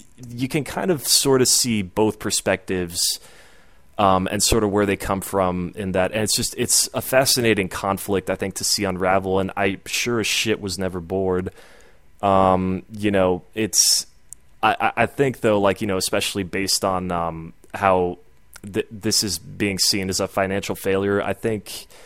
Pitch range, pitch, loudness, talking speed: 95-110 Hz, 100 Hz, -20 LUFS, 180 wpm